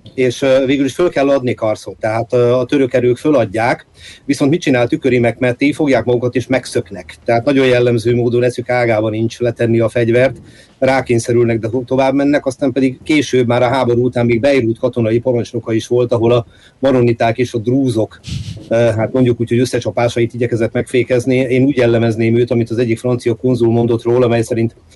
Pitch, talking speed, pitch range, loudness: 120 Hz, 185 wpm, 115-130 Hz, -14 LUFS